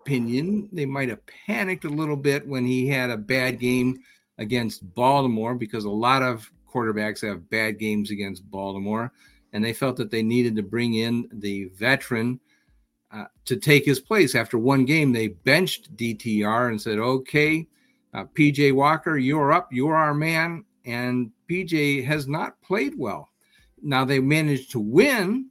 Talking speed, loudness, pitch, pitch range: 165 wpm, -23 LUFS, 125 Hz, 115-145 Hz